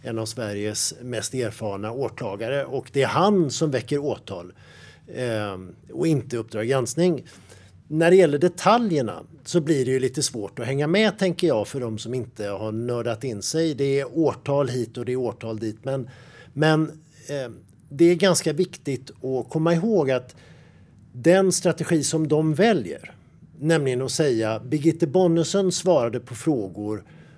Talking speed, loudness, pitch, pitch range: 165 wpm, -23 LUFS, 135 Hz, 115-165 Hz